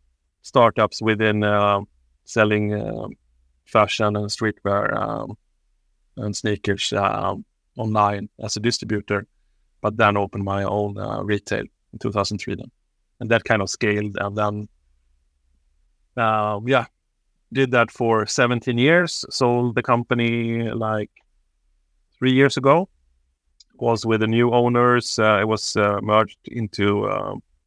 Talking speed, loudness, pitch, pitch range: 130 wpm, -21 LUFS, 105 Hz, 100-115 Hz